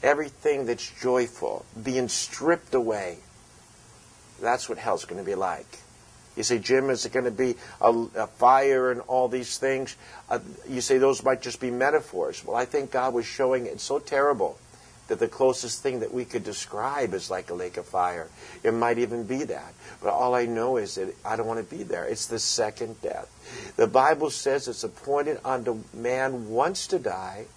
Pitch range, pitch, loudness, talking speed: 120-135 Hz, 130 Hz, -26 LUFS, 195 wpm